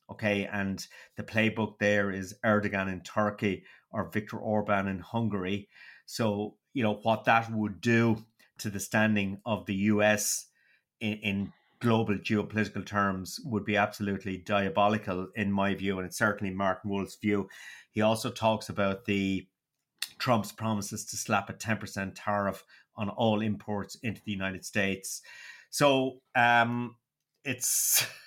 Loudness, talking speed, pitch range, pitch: -30 LUFS, 140 wpm, 100-110 Hz, 105 Hz